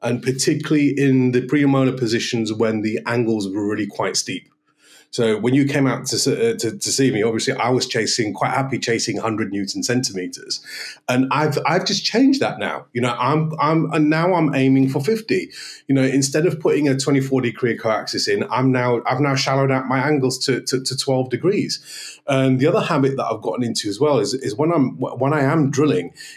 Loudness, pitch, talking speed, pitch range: -19 LUFS, 130 Hz, 210 wpm, 120-145 Hz